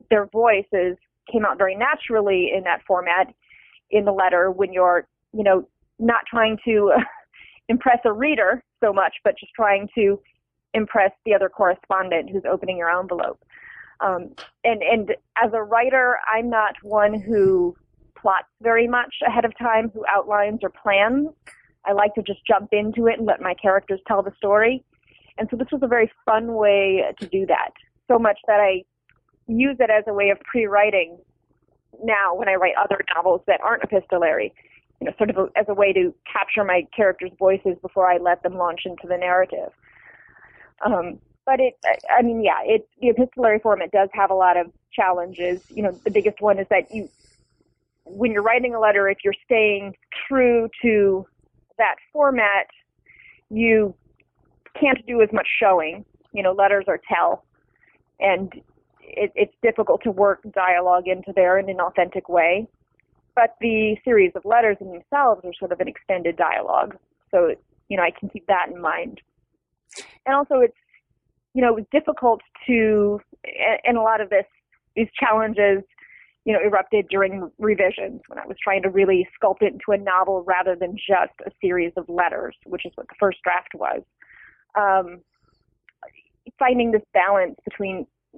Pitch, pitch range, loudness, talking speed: 205 Hz, 190-230 Hz, -20 LUFS, 175 wpm